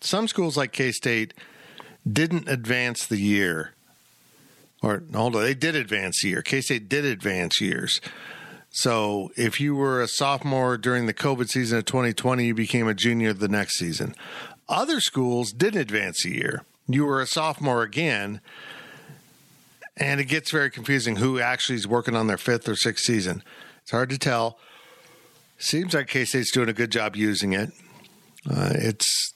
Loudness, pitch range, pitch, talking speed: -24 LUFS, 110-140 Hz, 125 Hz, 170 wpm